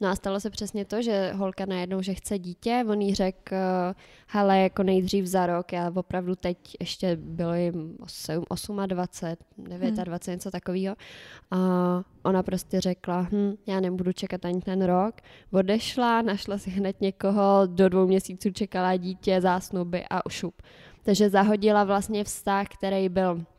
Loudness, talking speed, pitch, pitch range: -27 LUFS, 165 wpm, 190 Hz, 180-200 Hz